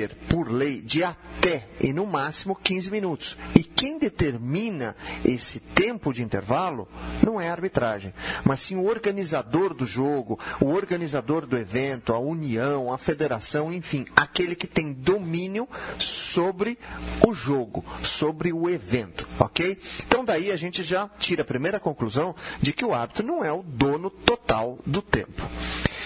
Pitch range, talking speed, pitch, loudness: 130-185 Hz, 150 wpm, 160 Hz, -26 LUFS